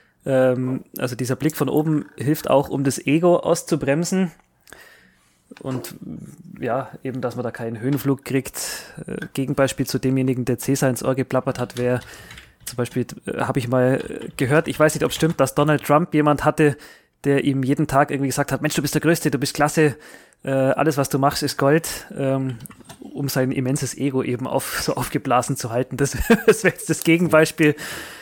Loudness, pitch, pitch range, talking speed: -21 LUFS, 140 Hz, 130-150 Hz, 180 wpm